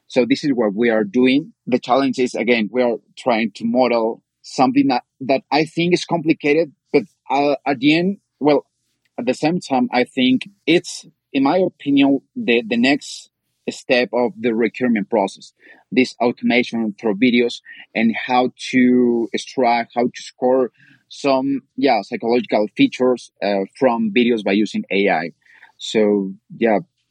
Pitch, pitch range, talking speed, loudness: 125 Hz, 120-145 Hz, 155 wpm, -18 LUFS